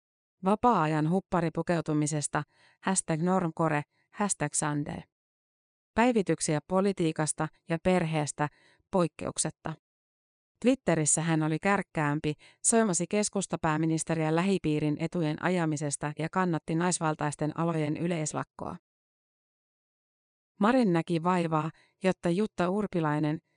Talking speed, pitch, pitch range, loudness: 80 wpm, 165 Hz, 155-185 Hz, -29 LUFS